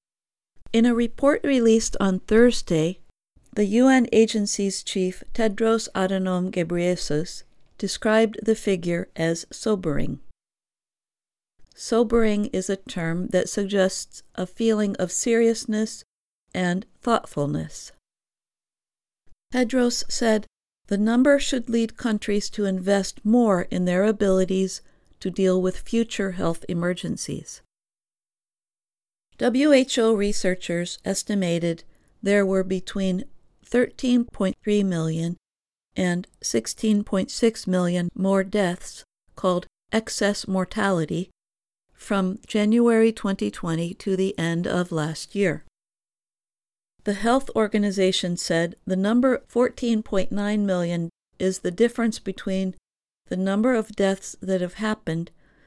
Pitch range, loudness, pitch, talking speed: 185-225 Hz, -23 LUFS, 200 Hz, 100 wpm